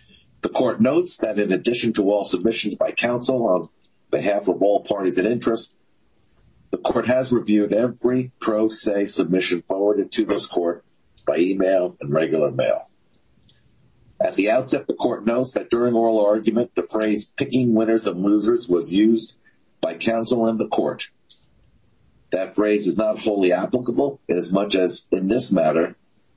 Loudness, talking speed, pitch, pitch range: -21 LUFS, 160 wpm, 110 Hz, 100-120 Hz